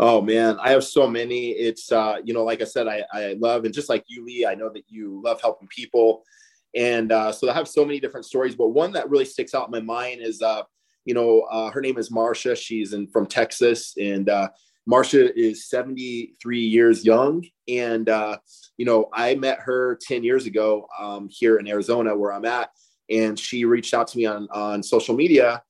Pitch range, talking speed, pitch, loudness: 110-120 Hz, 215 wpm, 115 Hz, -22 LUFS